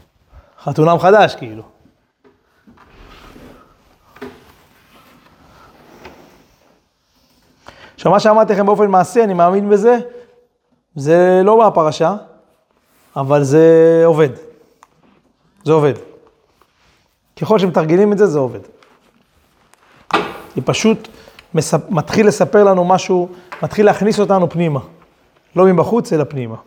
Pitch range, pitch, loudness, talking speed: 155-210 Hz, 180 Hz, -13 LUFS, 90 wpm